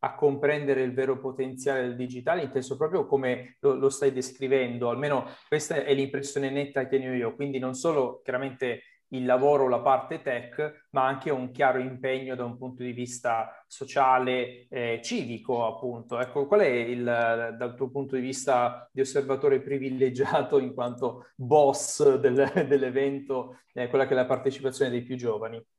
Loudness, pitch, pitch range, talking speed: -27 LUFS, 130 Hz, 125-140 Hz, 170 wpm